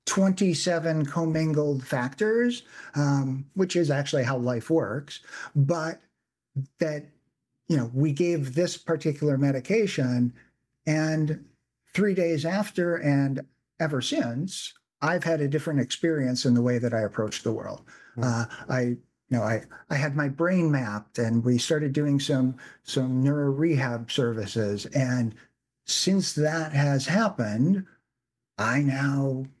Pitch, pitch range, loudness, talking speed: 145 Hz, 125-165 Hz, -26 LUFS, 130 wpm